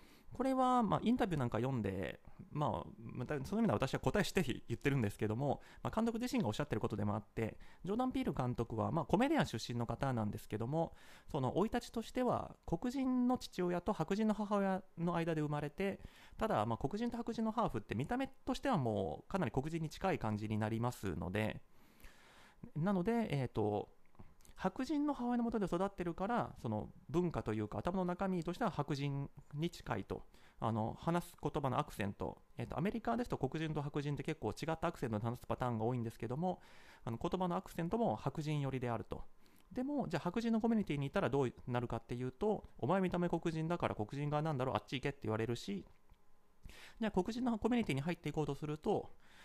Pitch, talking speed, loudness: 155 Hz, 435 characters per minute, -39 LUFS